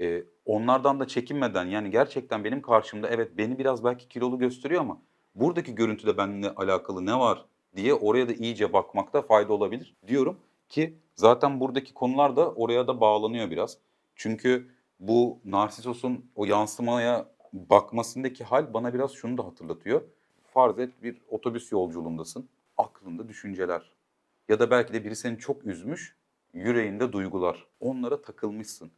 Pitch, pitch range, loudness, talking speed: 120 Hz, 105-125 Hz, -27 LUFS, 140 wpm